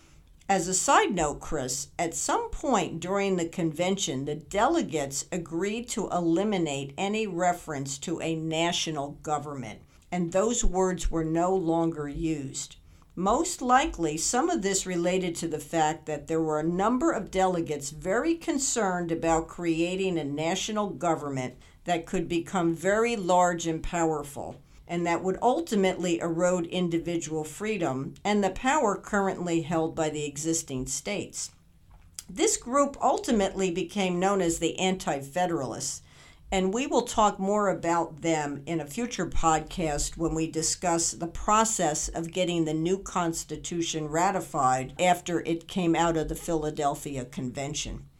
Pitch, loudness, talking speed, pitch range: 170 Hz, -28 LUFS, 140 wpm, 155-190 Hz